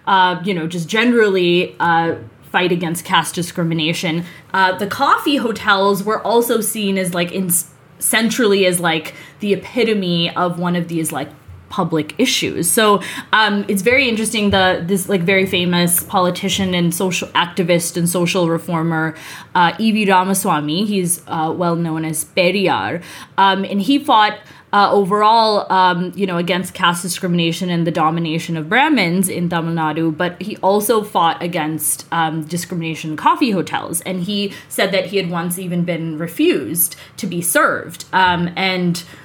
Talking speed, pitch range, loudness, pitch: 155 wpm, 165-200 Hz, -16 LUFS, 180 Hz